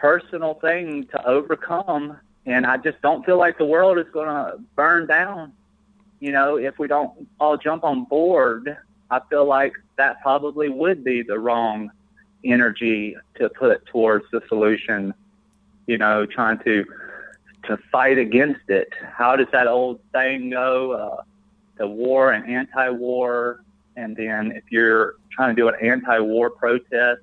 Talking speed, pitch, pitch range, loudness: 155 wpm, 130 Hz, 120-160 Hz, -20 LUFS